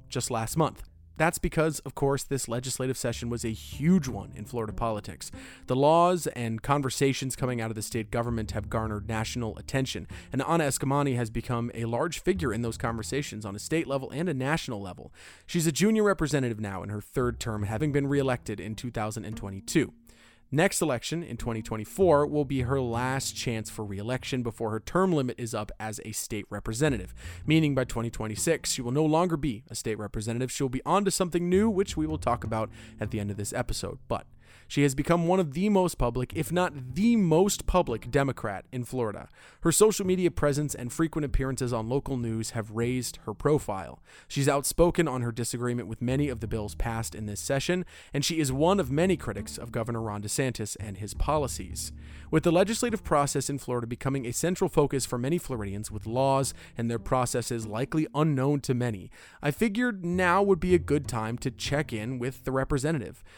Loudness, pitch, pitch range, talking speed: -28 LUFS, 125 Hz, 110-150 Hz, 200 wpm